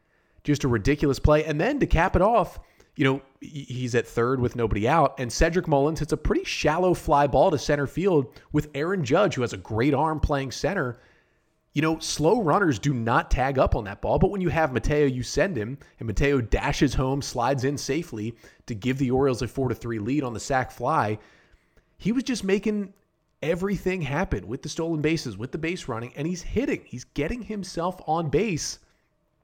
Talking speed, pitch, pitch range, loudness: 205 wpm, 145 Hz, 130-165 Hz, -25 LUFS